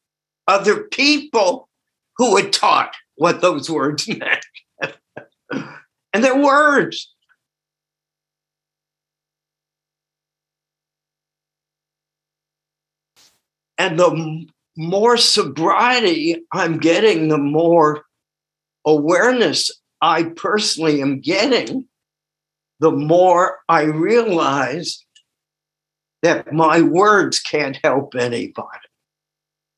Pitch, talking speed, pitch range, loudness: 155 Hz, 70 wpm, 155-190 Hz, -16 LUFS